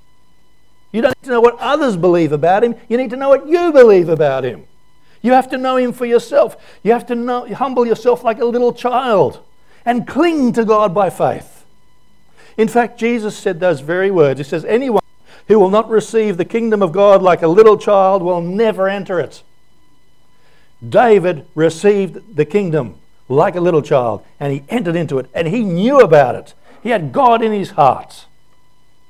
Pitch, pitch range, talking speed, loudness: 215 Hz, 180-240 Hz, 190 wpm, -14 LUFS